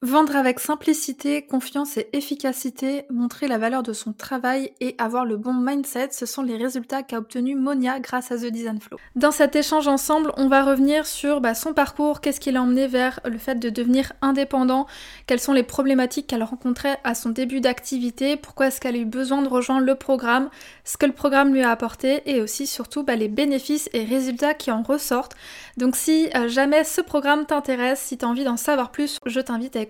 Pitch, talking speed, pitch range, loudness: 265 Hz, 205 wpm, 250-285 Hz, -22 LUFS